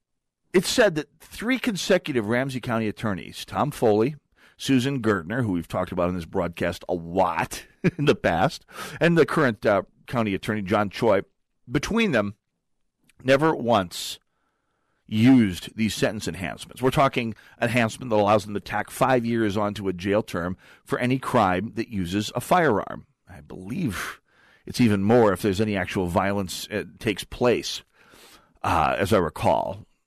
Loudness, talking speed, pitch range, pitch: -24 LUFS, 155 wpm, 100-130 Hz, 110 Hz